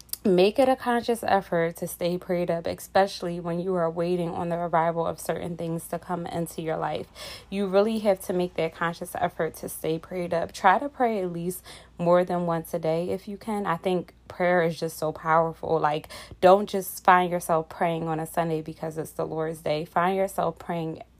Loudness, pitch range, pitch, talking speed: -26 LUFS, 165-185 Hz, 175 Hz, 210 wpm